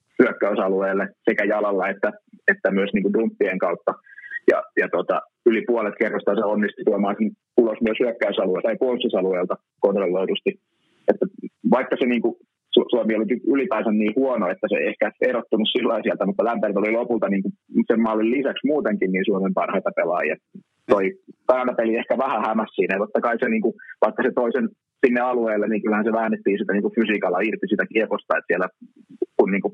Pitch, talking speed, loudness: 115 Hz, 175 wpm, -22 LUFS